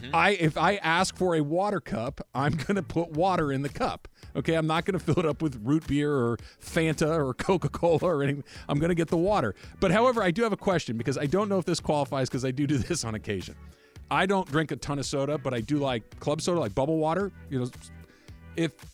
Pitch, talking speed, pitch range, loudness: 150 Hz, 250 wpm, 135-170 Hz, -27 LUFS